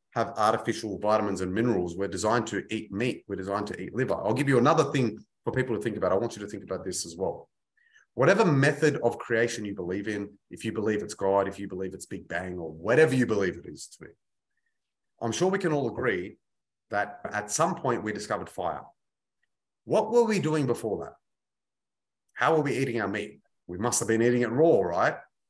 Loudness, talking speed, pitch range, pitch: -27 LUFS, 220 wpm, 100-145 Hz, 110 Hz